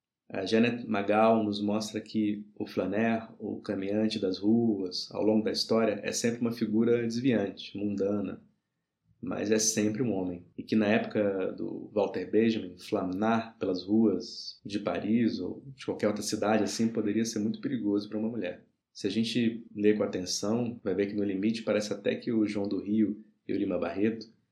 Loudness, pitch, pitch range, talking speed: -30 LUFS, 110 Hz, 105-115 Hz, 180 wpm